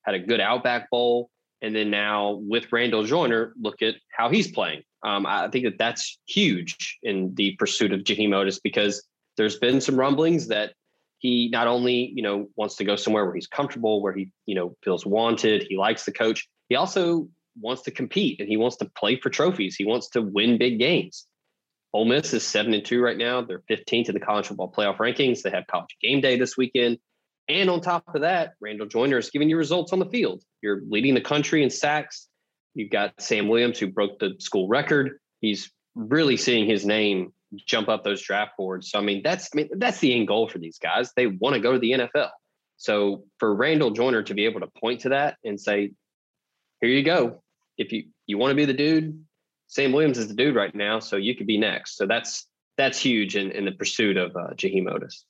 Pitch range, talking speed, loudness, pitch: 105-135 Hz, 220 wpm, -24 LUFS, 115 Hz